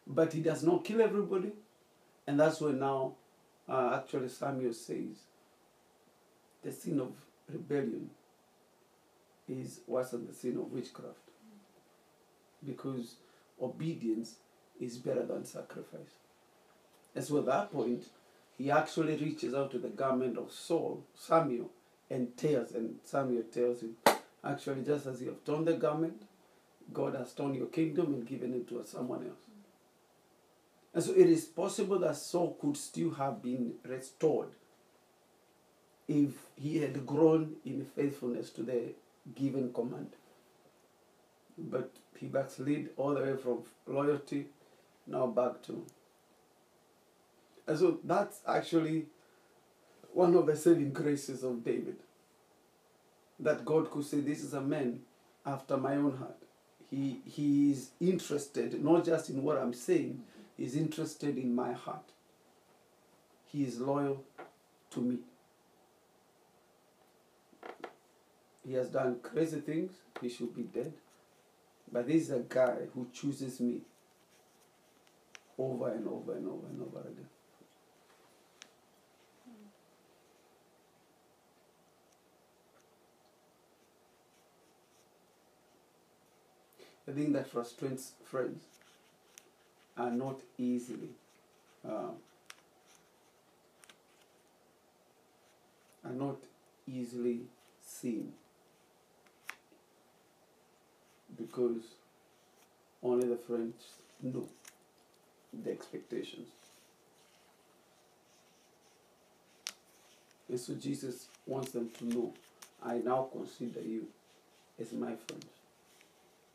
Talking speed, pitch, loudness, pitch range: 105 wpm, 135 Hz, -35 LUFS, 125-155 Hz